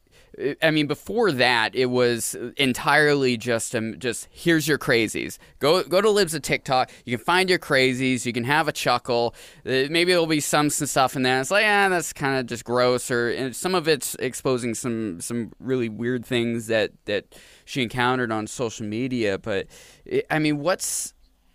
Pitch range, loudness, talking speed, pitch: 120-150 Hz, -23 LUFS, 190 wpm, 130 Hz